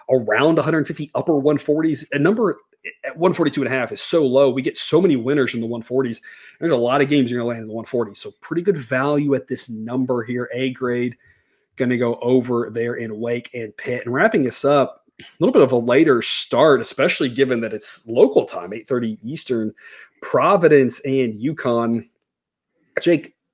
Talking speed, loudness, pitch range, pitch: 190 wpm, -19 LUFS, 120-145 Hz, 125 Hz